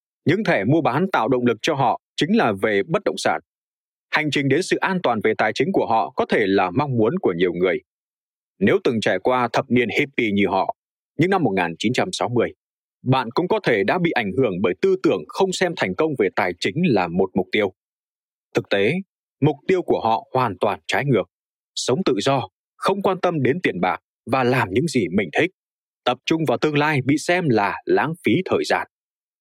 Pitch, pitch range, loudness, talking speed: 140 Hz, 120-175 Hz, -21 LUFS, 215 wpm